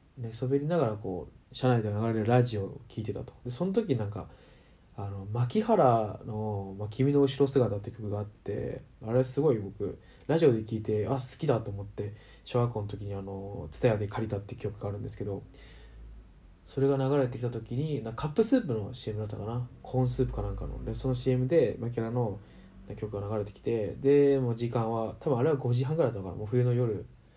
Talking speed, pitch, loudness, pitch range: 390 characters per minute, 115 Hz, -30 LUFS, 105-130 Hz